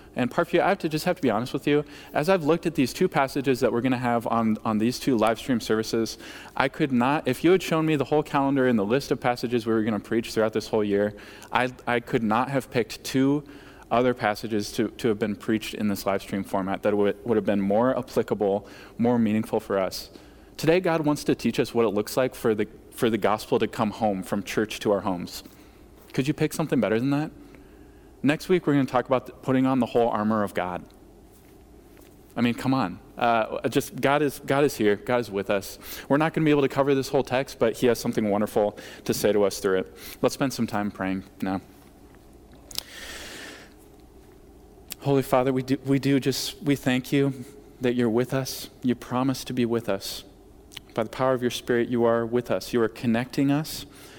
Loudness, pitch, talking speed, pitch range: -25 LUFS, 125 Hz, 230 wpm, 110-140 Hz